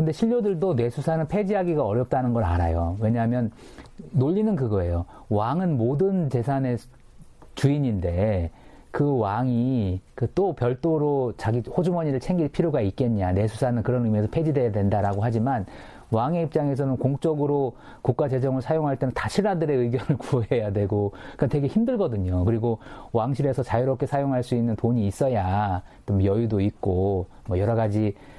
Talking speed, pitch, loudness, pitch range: 355 characters per minute, 125 Hz, -24 LUFS, 105-145 Hz